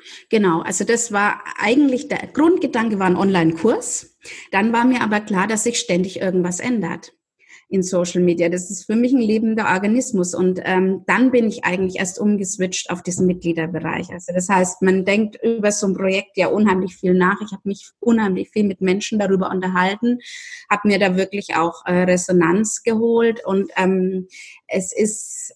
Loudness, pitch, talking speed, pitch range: -19 LUFS, 195 Hz, 175 wpm, 185-220 Hz